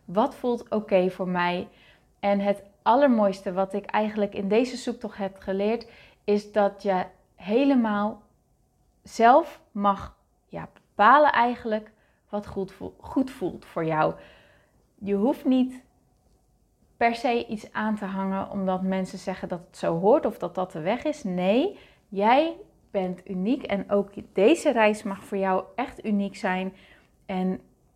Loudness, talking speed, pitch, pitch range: -25 LUFS, 150 wpm, 205 Hz, 195-235 Hz